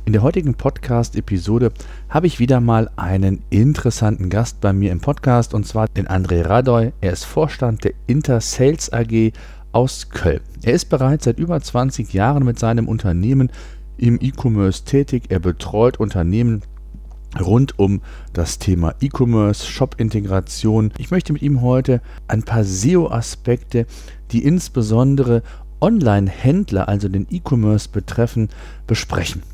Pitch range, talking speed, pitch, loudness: 100-125 Hz, 135 wpm, 115 Hz, -18 LUFS